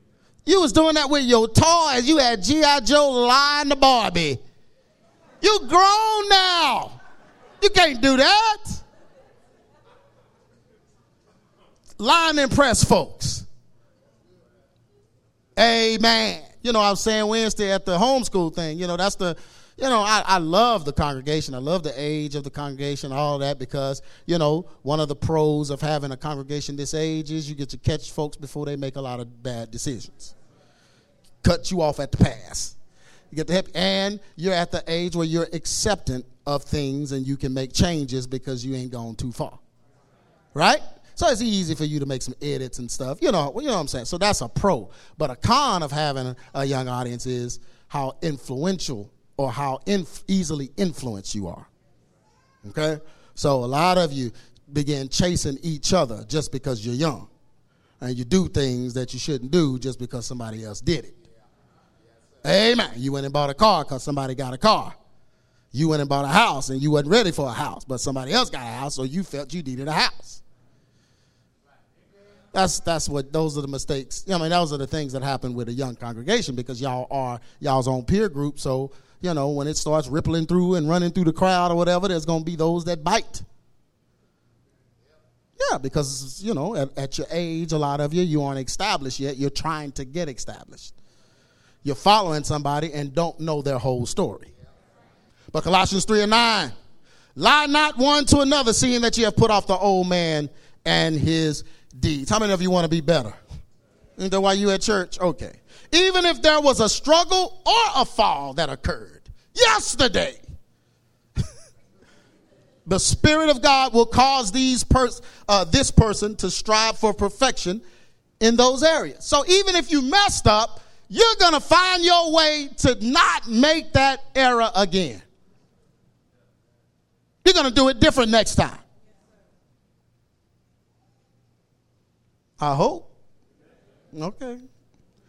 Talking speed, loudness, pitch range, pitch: 175 wpm, -21 LUFS, 135-220 Hz, 160 Hz